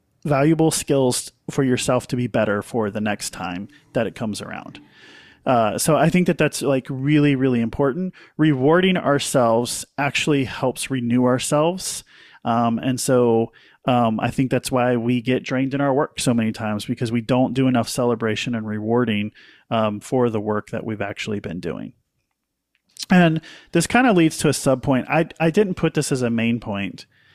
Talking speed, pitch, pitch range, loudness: 180 wpm, 130 Hz, 115-150 Hz, -20 LUFS